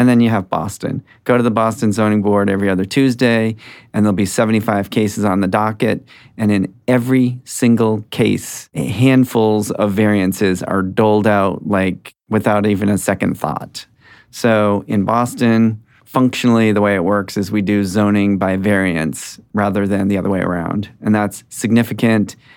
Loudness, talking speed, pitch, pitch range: -16 LUFS, 170 wpm, 105 Hz, 100-115 Hz